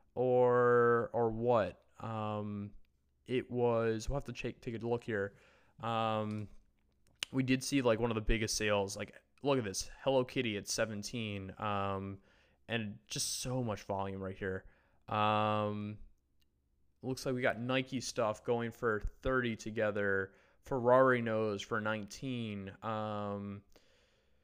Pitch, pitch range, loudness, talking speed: 110 Hz, 100-120 Hz, -35 LUFS, 140 wpm